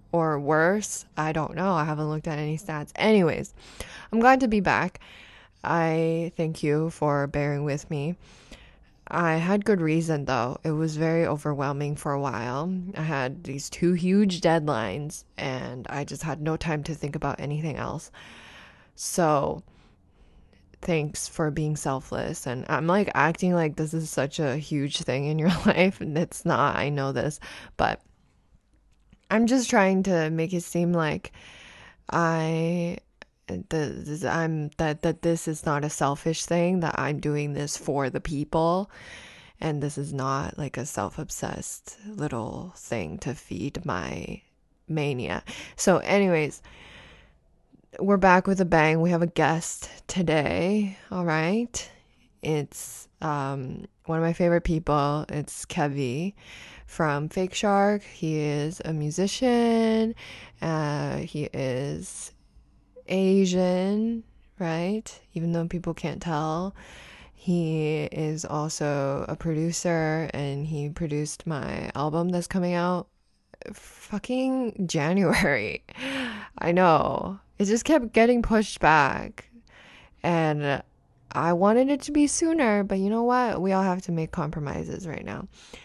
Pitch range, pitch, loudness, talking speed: 150-185 Hz, 160 Hz, -26 LUFS, 140 wpm